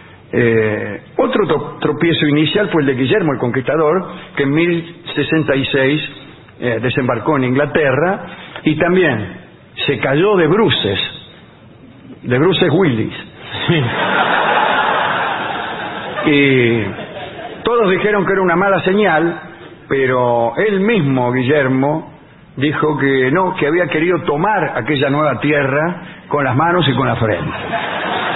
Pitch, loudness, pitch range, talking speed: 150 Hz, -15 LUFS, 135-170 Hz, 120 wpm